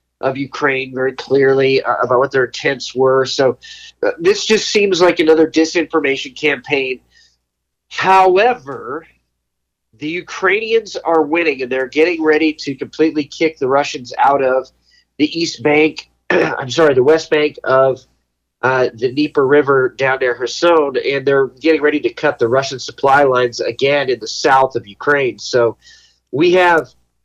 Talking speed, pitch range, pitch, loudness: 155 wpm, 130-160 Hz, 140 Hz, -15 LUFS